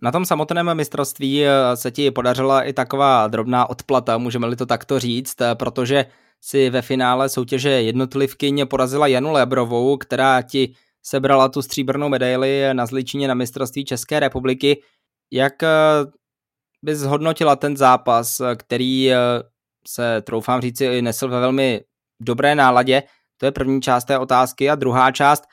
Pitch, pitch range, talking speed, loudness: 130 Hz, 125-140 Hz, 140 wpm, -18 LUFS